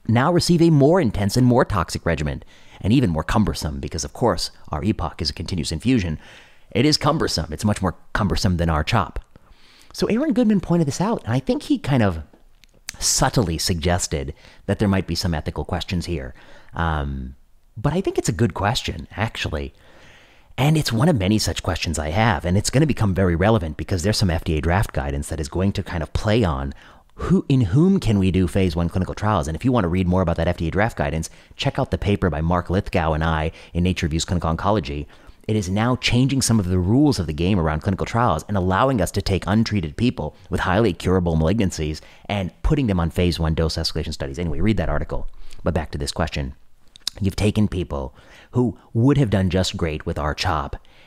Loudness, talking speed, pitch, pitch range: -21 LUFS, 215 wpm, 90 Hz, 80-110 Hz